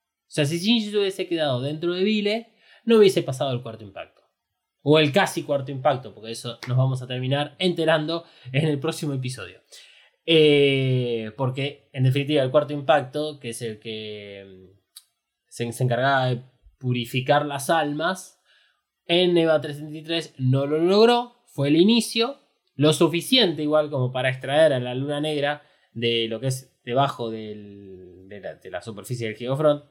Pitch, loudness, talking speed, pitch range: 145 Hz, -23 LUFS, 160 wpm, 125-165 Hz